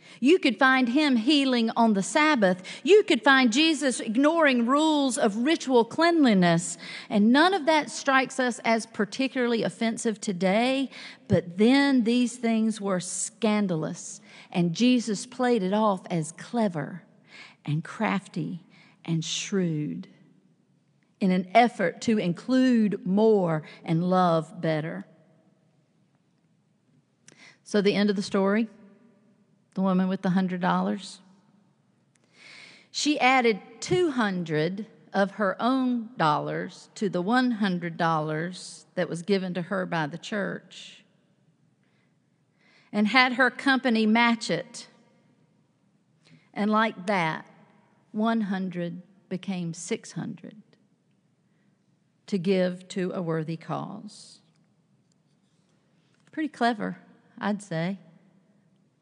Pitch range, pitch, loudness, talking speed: 180-235 Hz, 200 Hz, -25 LUFS, 110 wpm